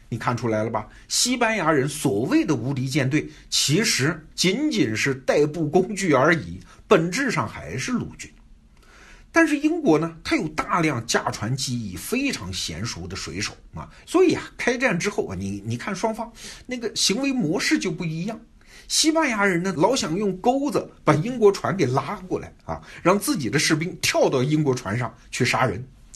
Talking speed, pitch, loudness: 260 characters per minute, 155 Hz, -22 LUFS